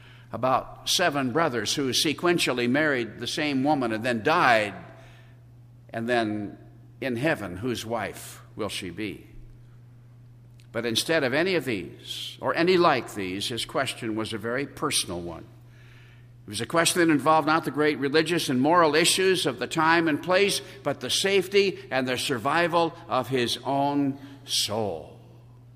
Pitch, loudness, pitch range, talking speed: 125 Hz, -25 LUFS, 120-155 Hz, 155 wpm